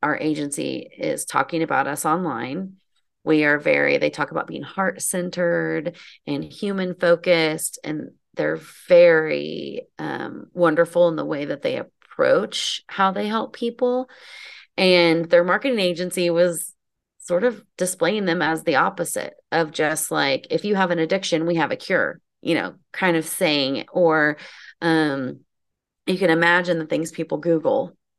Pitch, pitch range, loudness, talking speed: 175 Hz, 160-190 Hz, -21 LUFS, 155 wpm